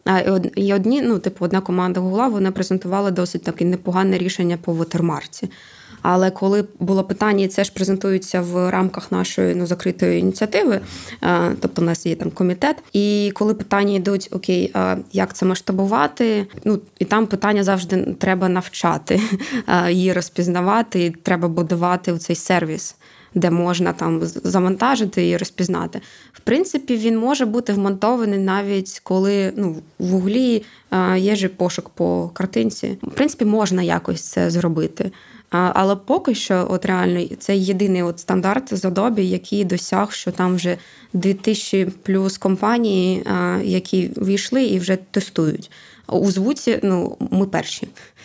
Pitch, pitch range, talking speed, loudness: 190 Hz, 180-200 Hz, 145 wpm, -19 LUFS